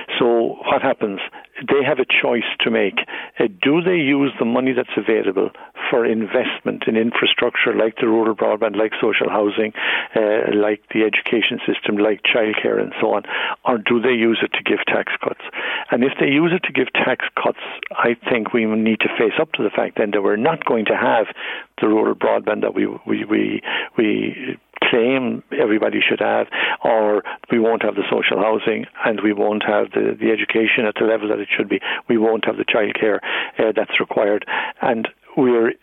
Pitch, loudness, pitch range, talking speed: 110 Hz, -18 LUFS, 105-120 Hz, 200 wpm